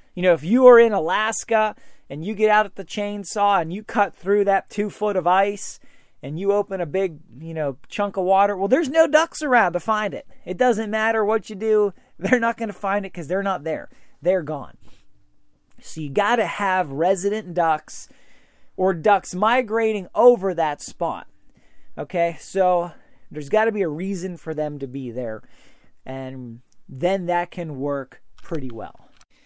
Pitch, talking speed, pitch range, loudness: 195 Hz, 185 wpm, 160-215 Hz, -21 LUFS